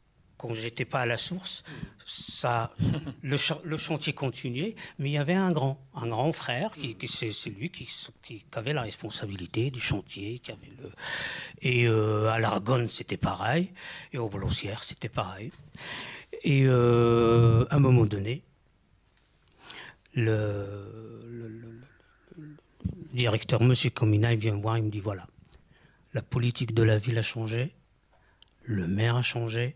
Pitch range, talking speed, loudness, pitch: 110-135 Hz, 165 wpm, -28 LUFS, 120 Hz